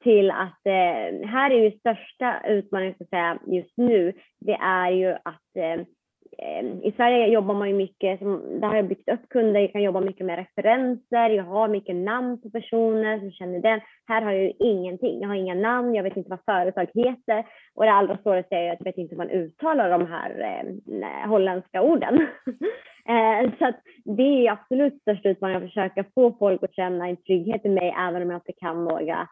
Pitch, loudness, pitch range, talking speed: 200 Hz, -24 LUFS, 185-225 Hz, 205 wpm